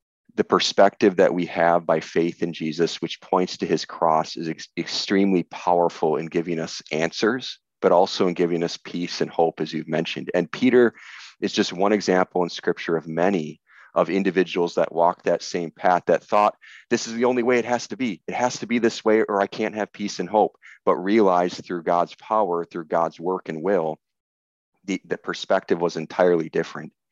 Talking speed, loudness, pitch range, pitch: 200 wpm, -23 LUFS, 85-105 Hz, 90 Hz